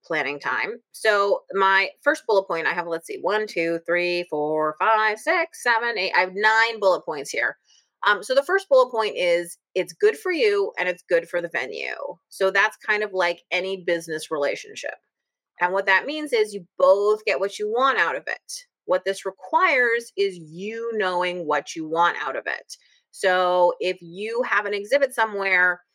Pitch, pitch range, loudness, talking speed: 195 Hz, 175-230 Hz, -22 LUFS, 190 wpm